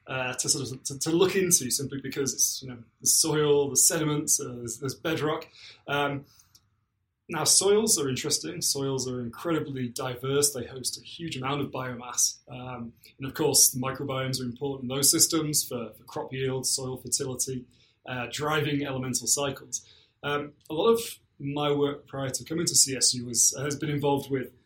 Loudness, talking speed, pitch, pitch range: -26 LUFS, 180 wpm, 135 Hz, 125-145 Hz